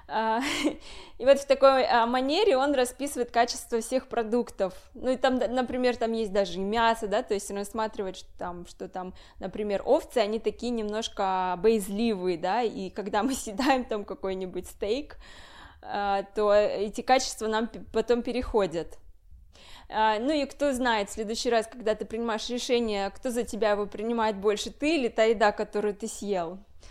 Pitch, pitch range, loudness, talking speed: 220 Hz, 205-245 Hz, -27 LUFS, 160 wpm